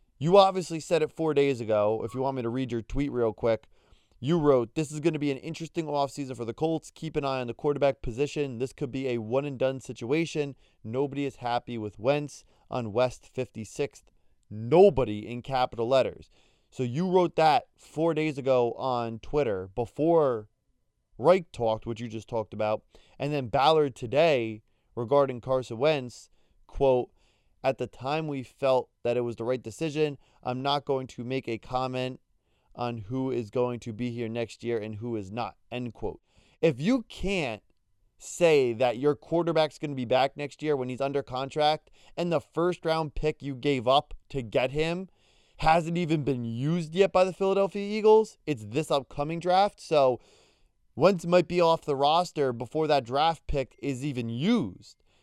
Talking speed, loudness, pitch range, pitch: 185 wpm, -28 LUFS, 120-155 Hz, 135 Hz